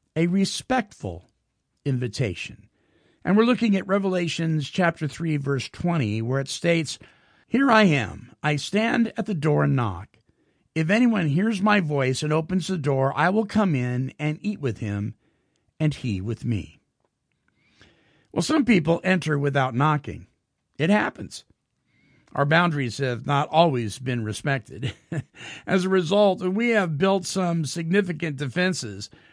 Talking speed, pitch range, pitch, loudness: 145 wpm, 130-185 Hz, 150 Hz, -23 LUFS